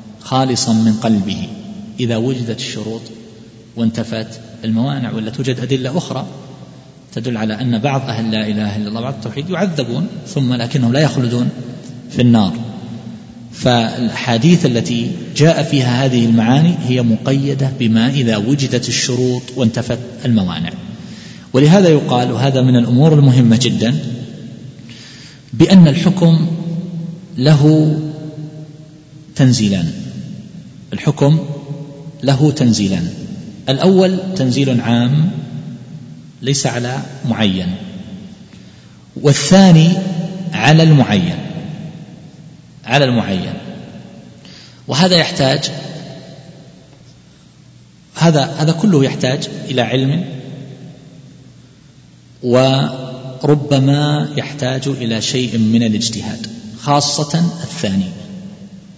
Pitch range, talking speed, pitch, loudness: 120-160 Hz, 85 wpm, 135 Hz, -14 LUFS